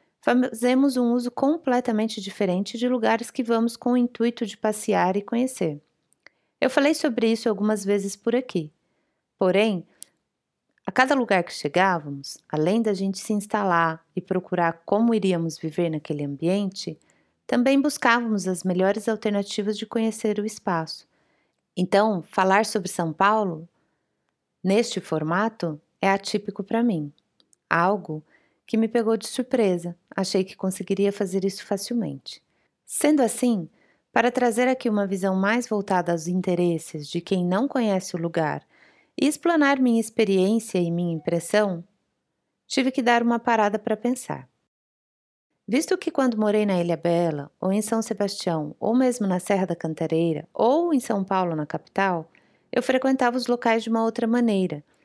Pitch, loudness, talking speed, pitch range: 205 Hz, -24 LUFS, 150 wpm, 180-235 Hz